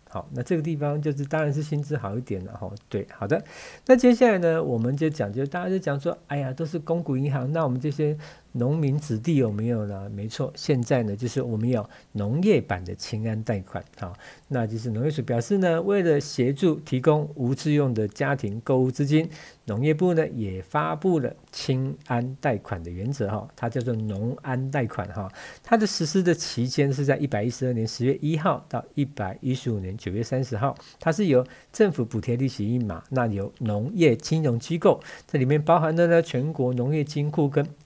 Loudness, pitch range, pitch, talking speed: -25 LUFS, 115-155 Hz, 135 Hz, 300 characters per minute